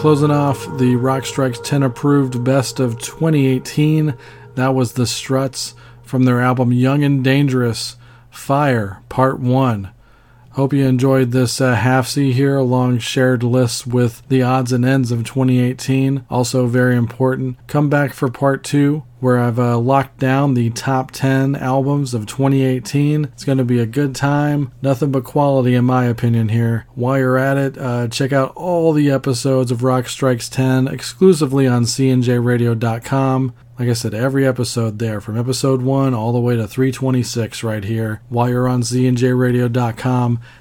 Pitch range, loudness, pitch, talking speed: 120-135 Hz, -16 LUFS, 130 Hz, 165 wpm